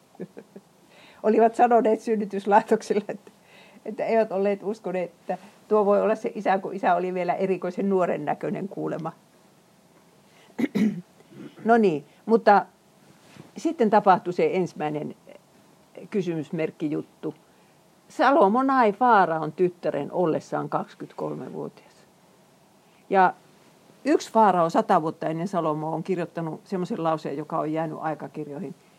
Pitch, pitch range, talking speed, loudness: 190 Hz, 170-215 Hz, 105 wpm, -24 LUFS